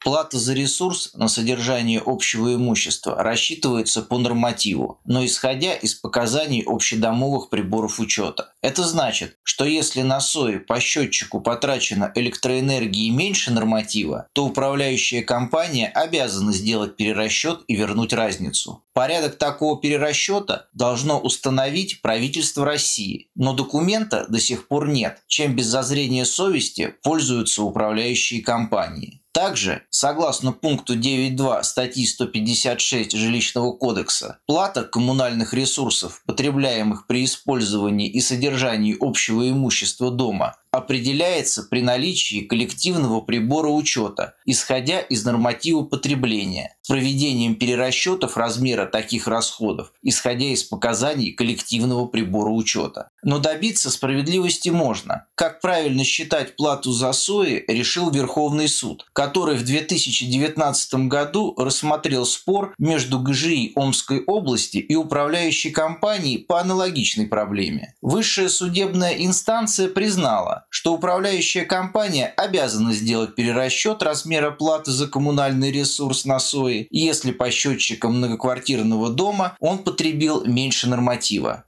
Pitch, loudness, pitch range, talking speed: 130 Hz, -21 LUFS, 120-150 Hz, 115 wpm